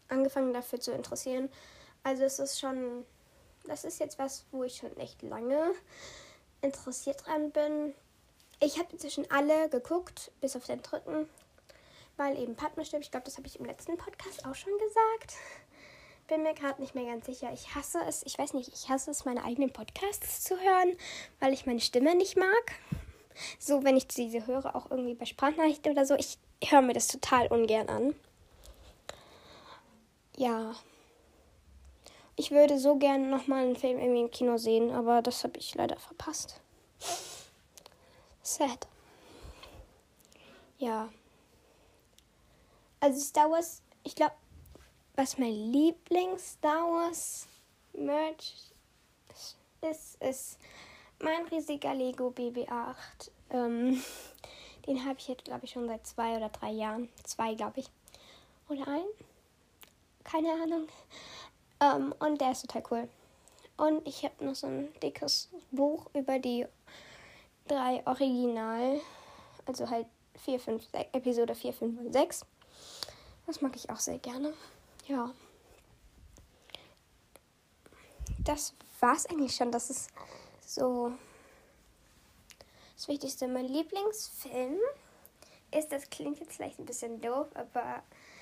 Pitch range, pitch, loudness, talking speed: 245-305 Hz, 275 Hz, -33 LUFS, 135 wpm